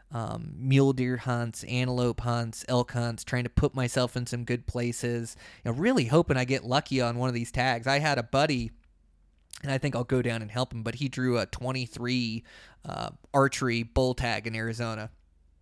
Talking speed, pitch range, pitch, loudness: 205 wpm, 115-130 Hz, 120 Hz, -29 LUFS